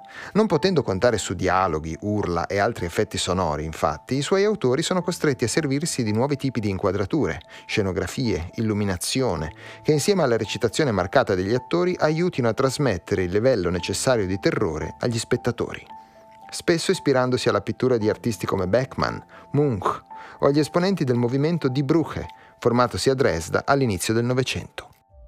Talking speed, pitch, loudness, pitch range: 150 wpm, 120 Hz, -23 LUFS, 100-145 Hz